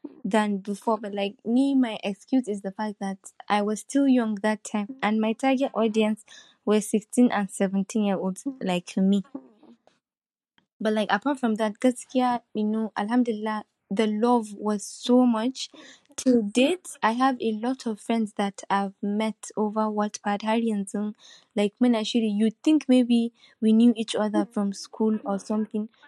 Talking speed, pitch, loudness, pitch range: 170 wpm, 220 Hz, -25 LUFS, 205-245 Hz